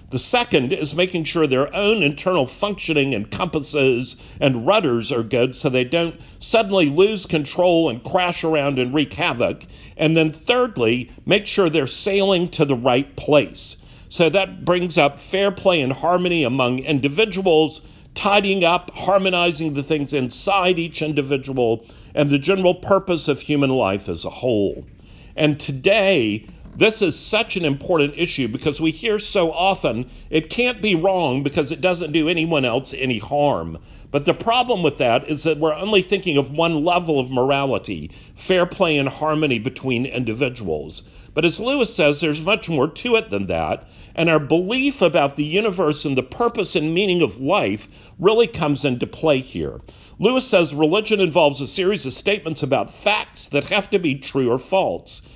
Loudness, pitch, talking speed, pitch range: -19 LUFS, 155 Hz, 170 wpm, 135-185 Hz